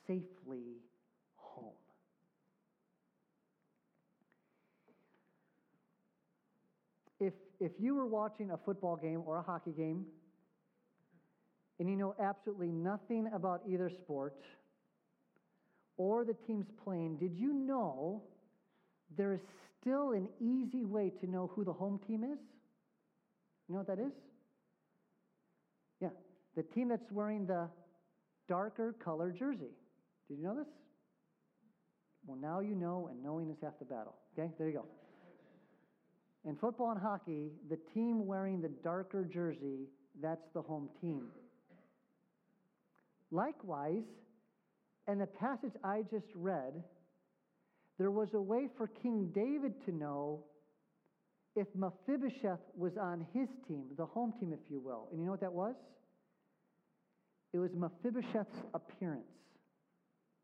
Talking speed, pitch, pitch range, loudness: 125 wpm, 190 Hz, 170-220 Hz, -41 LUFS